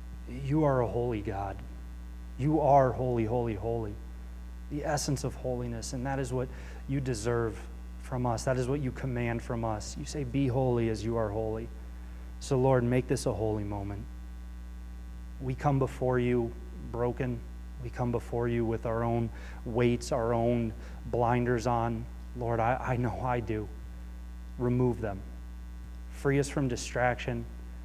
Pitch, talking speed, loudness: 115 Hz, 155 wpm, -31 LUFS